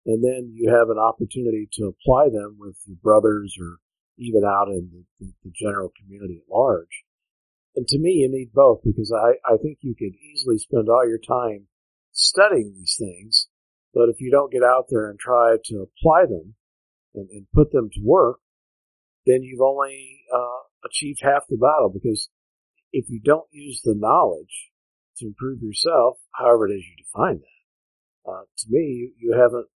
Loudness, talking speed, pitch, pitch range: -20 LUFS, 185 wpm, 115 Hz, 100-130 Hz